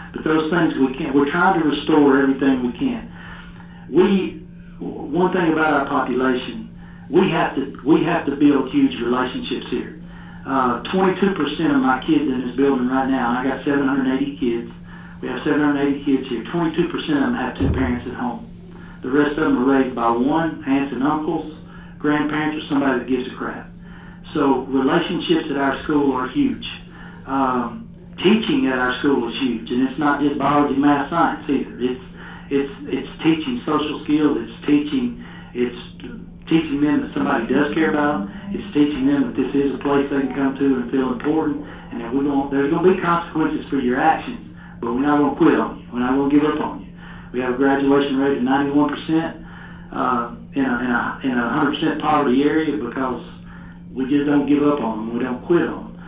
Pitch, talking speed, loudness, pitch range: 145 Hz, 200 wpm, -20 LUFS, 135-160 Hz